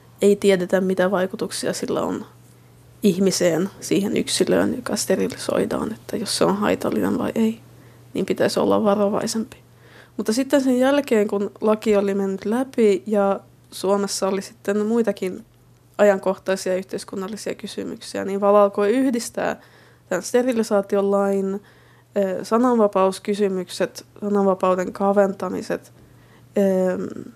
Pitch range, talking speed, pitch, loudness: 190-210 Hz, 105 wpm, 200 Hz, -21 LUFS